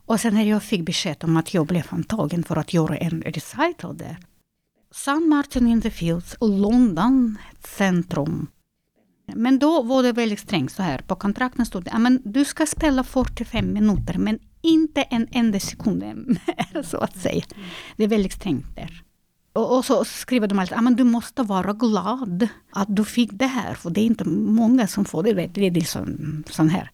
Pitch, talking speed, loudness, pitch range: 215 Hz, 185 wpm, -22 LUFS, 175-245 Hz